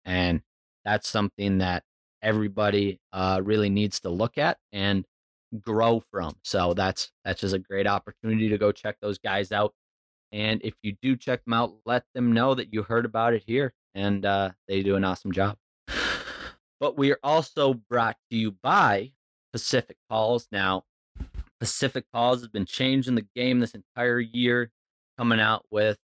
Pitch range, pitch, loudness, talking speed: 100-120 Hz, 105 Hz, -26 LUFS, 170 wpm